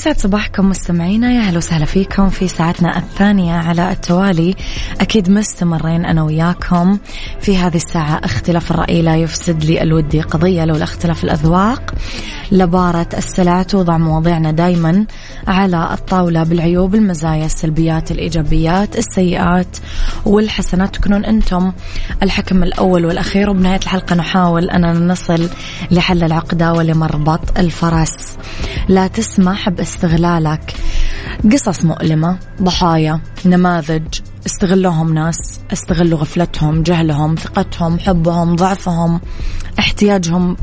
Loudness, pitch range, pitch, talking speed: -14 LUFS, 165-190 Hz, 175 Hz, 105 wpm